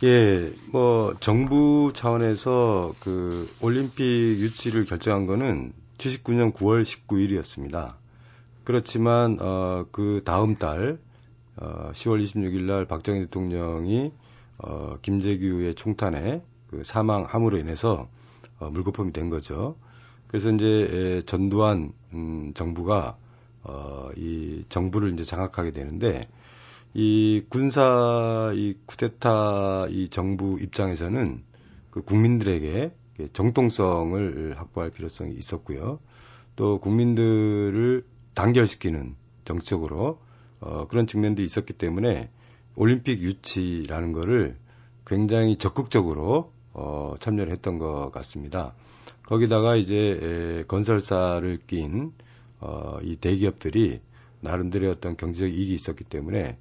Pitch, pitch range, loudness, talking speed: 105 Hz, 90-120 Hz, -25 LUFS, 240 characters per minute